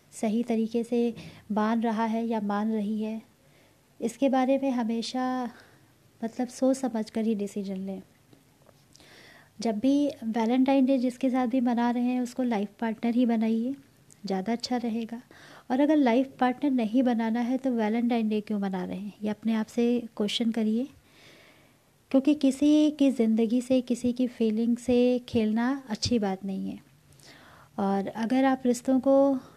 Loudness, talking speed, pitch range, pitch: -27 LUFS, 160 wpm, 220-255 Hz, 235 Hz